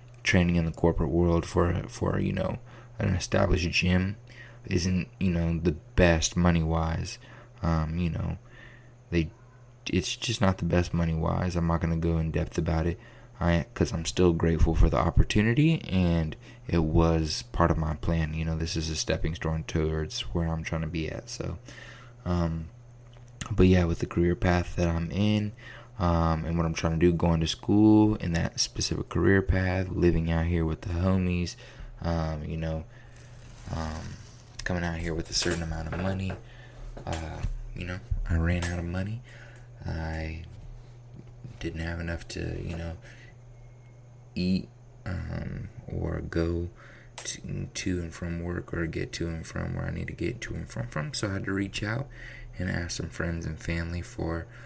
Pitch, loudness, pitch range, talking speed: 90 Hz, -28 LUFS, 85-115 Hz, 180 wpm